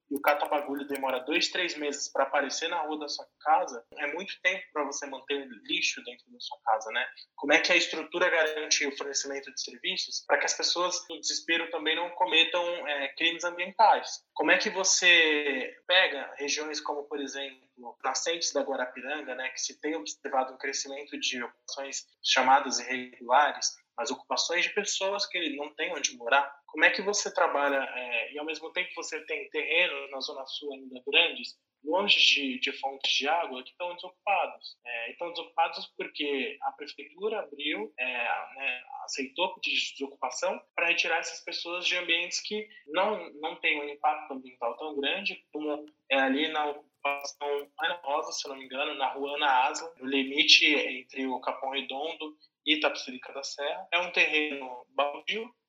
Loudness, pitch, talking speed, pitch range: -28 LUFS, 150 Hz, 175 wpm, 140-175 Hz